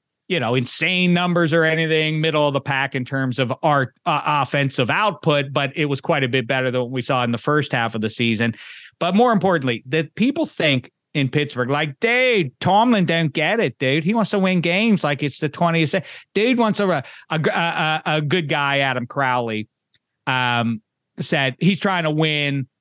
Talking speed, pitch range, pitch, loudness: 195 wpm, 130-175 Hz, 150 Hz, -19 LUFS